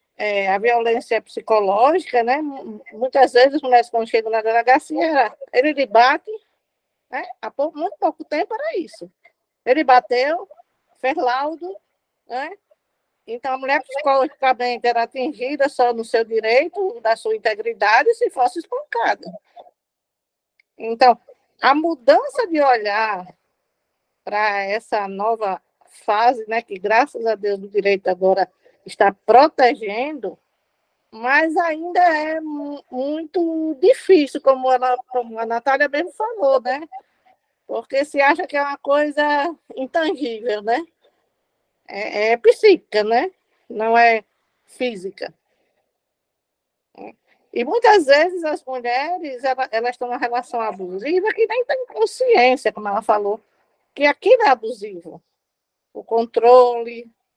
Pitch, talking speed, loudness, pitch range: 260 Hz, 125 wpm, -18 LUFS, 230-325 Hz